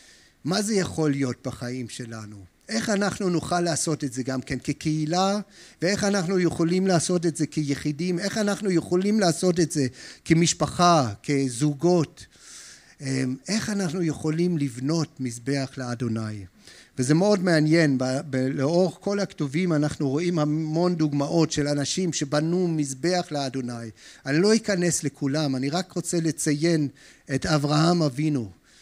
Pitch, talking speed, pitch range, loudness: 155 Hz, 130 wpm, 135-175 Hz, -24 LUFS